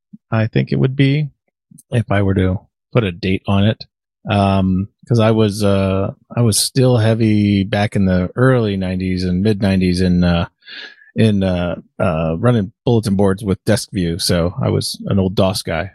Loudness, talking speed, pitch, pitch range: -16 LUFS, 185 wpm, 100 Hz, 95-110 Hz